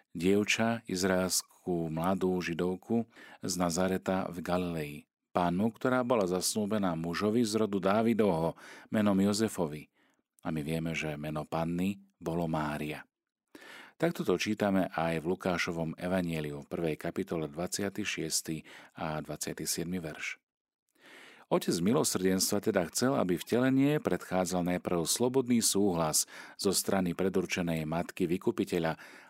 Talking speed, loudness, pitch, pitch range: 115 wpm, -31 LUFS, 90 Hz, 80-100 Hz